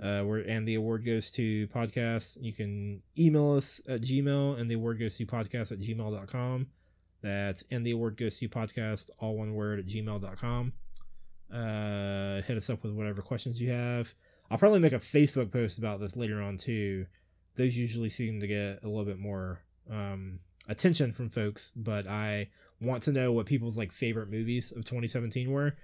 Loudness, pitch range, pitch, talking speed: -32 LUFS, 100-120 Hz, 110 Hz, 185 wpm